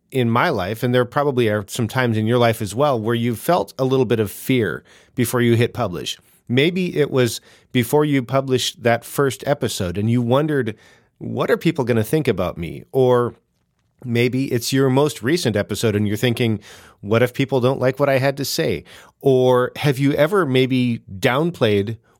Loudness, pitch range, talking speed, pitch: -19 LUFS, 115-135 Hz, 195 wpm, 125 Hz